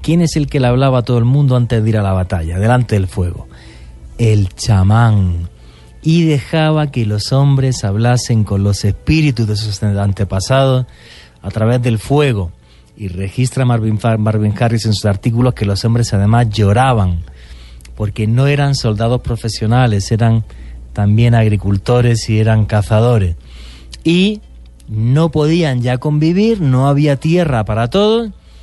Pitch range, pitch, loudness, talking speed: 100-130 Hz, 115 Hz, -14 LUFS, 150 wpm